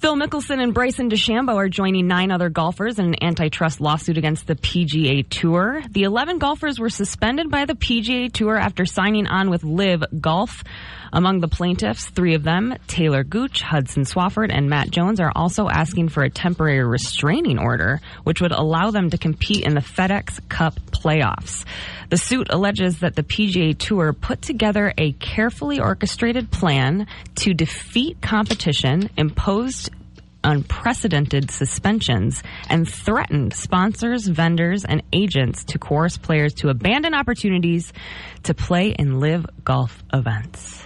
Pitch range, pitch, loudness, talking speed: 150-210 Hz, 175 Hz, -20 LUFS, 150 wpm